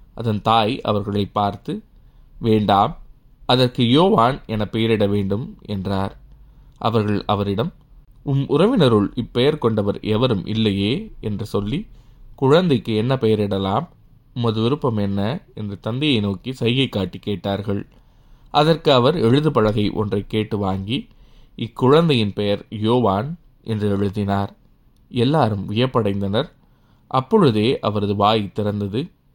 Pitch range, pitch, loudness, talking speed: 105-130 Hz, 110 Hz, -20 LUFS, 105 wpm